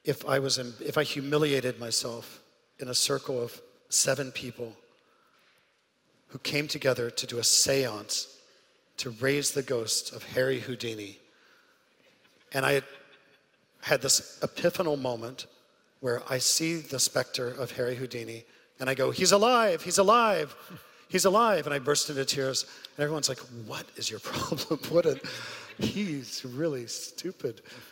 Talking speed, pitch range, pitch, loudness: 145 wpm, 125-150 Hz, 135 Hz, -28 LUFS